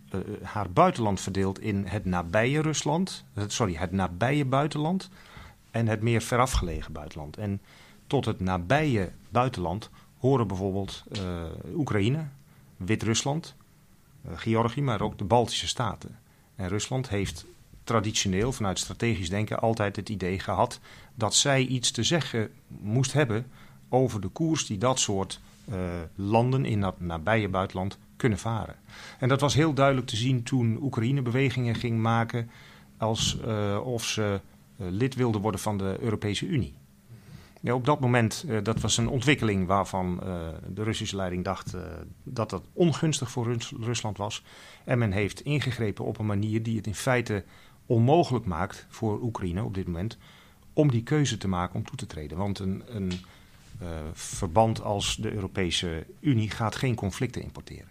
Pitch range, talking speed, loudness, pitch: 95-125 Hz, 160 wpm, -28 LUFS, 110 Hz